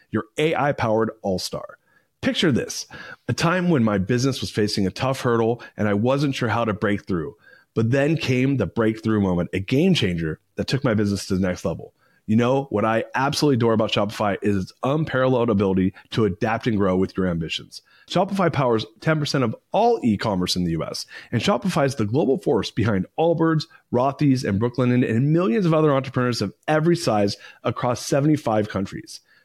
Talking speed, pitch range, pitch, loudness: 190 wpm, 105-140 Hz, 115 Hz, -22 LUFS